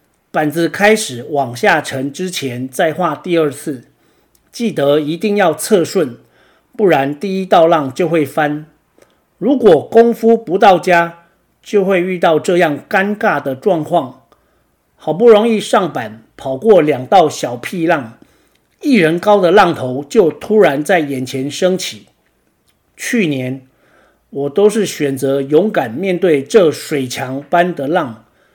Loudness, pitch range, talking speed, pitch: -14 LUFS, 140-195 Hz, 195 characters per minute, 165 Hz